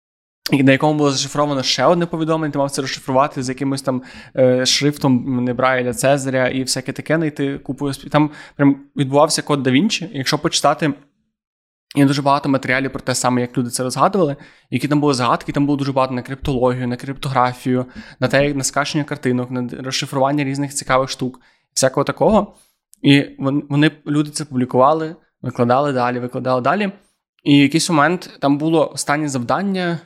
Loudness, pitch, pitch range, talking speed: -18 LUFS, 140 Hz, 130-150 Hz, 170 wpm